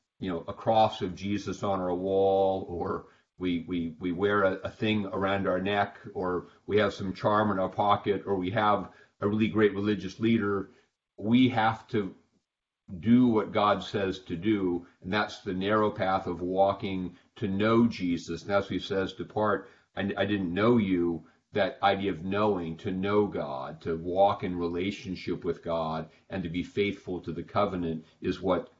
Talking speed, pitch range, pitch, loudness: 180 wpm, 90-105 Hz, 100 Hz, -29 LUFS